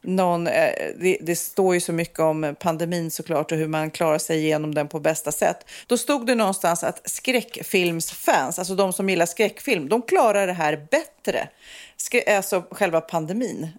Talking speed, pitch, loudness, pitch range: 170 wpm, 175 Hz, -23 LUFS, 160-200 Hz